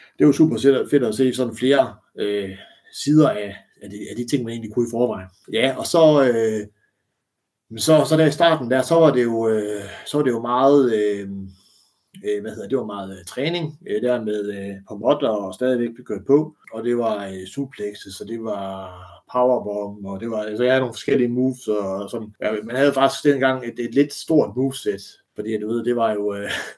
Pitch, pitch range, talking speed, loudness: 120 Hz, 105-135 Hz, 220 wpm, -21 LUFS